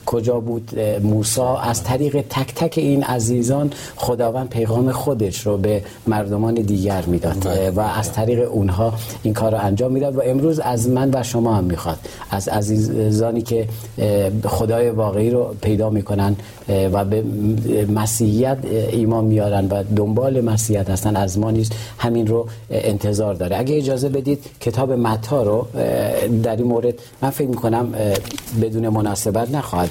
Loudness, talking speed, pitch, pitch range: -19 LUFS, 145 wpm, 110 Hz, 105-120 Hz